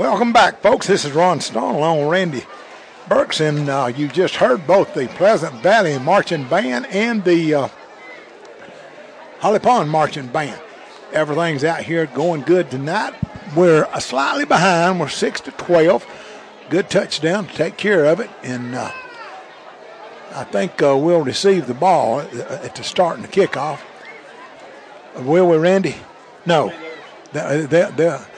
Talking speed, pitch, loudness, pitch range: 150 wpm, 165 Hz, -17 LUFS, 145-180 Hz